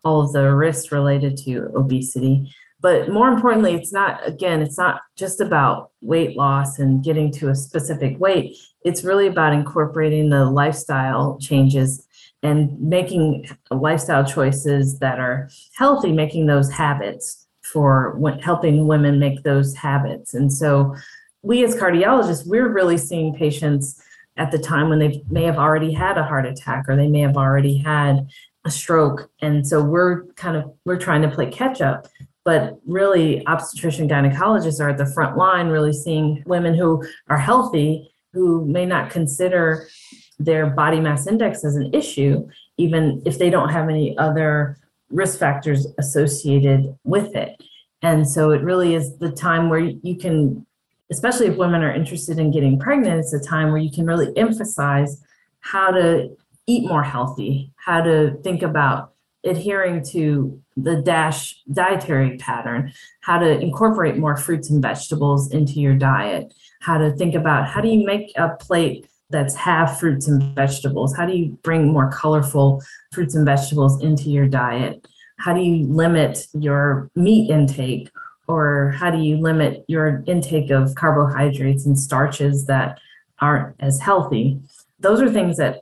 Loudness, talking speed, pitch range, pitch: -19 LUFS, 160 wpm, 140-170 Hz, 155 Hz